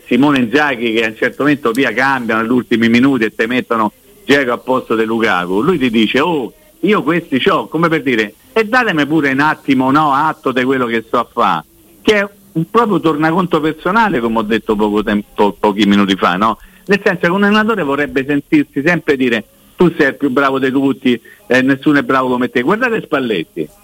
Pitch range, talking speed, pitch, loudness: 115-160 Hz, 205 wpm, 135 Hz, -14 LUFS